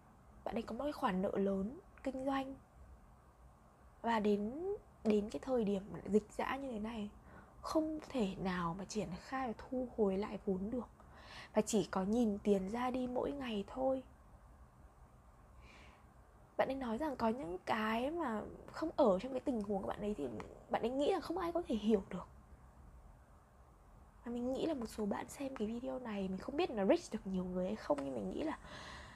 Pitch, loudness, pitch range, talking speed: 215 Hz, -39 LUFS, 190-260 Hz, 200 wpm